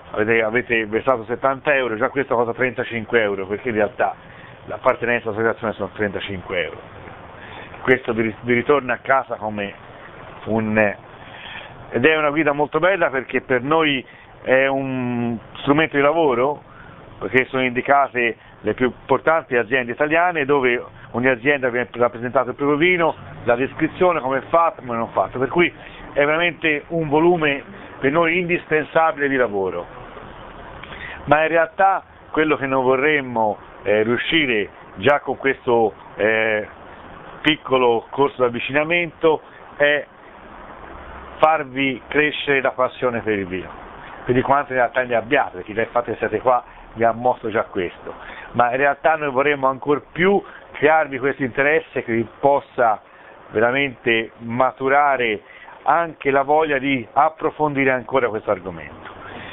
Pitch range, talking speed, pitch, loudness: 115-145 Hz, 140 wpm, 130 Hz, -19 LUFS